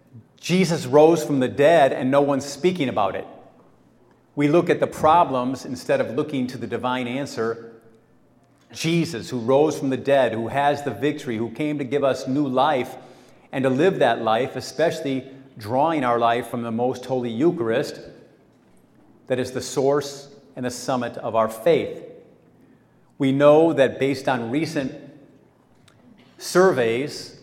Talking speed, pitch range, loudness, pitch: 155 wpm, 125-145 Hz, -21 LUFS, 135 Hz